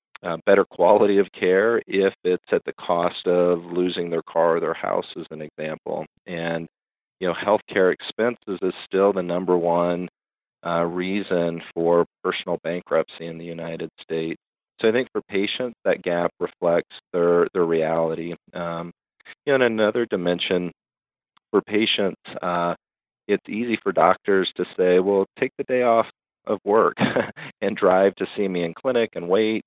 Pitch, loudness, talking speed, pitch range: 90 Hz, -22 LUFS, 160 wpm, 85-95 Hz